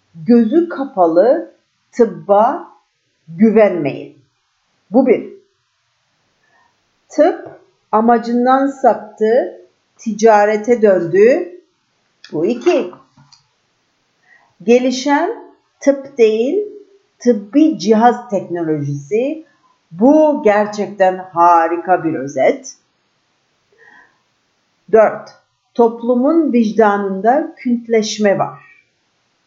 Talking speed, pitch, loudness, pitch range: 60 wpm, 235 Hz, -14 LUFS, 205-290 Hz